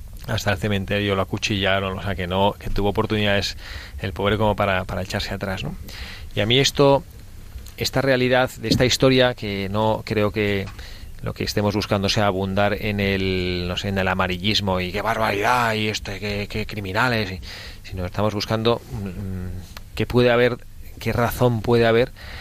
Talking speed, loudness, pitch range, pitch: 175 wpm, -21 LUFS, 95-110 Hz, 100 Hz